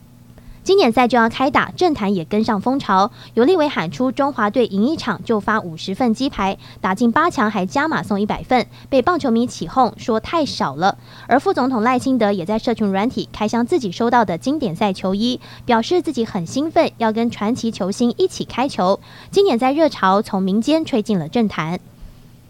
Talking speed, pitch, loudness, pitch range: 290 characters per minute, 230 Hz, -18 LUFS, 200-260 Hz